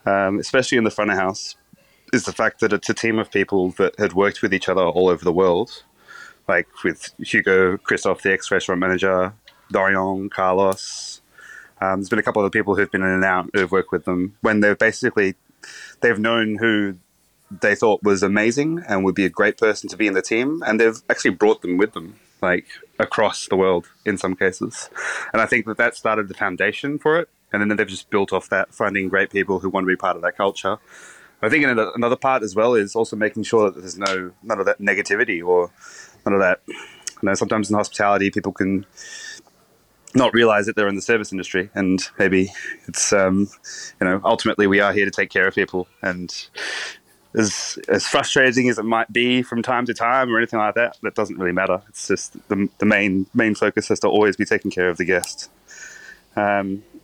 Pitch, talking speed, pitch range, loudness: 100 Hz, 215 wpm, 95-115 Hz, -20 LUFS